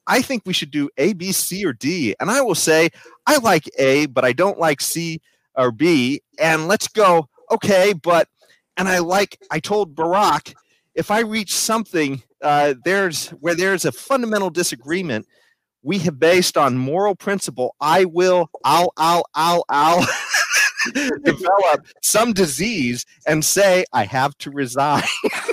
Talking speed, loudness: 155 wpm, -18 LUFS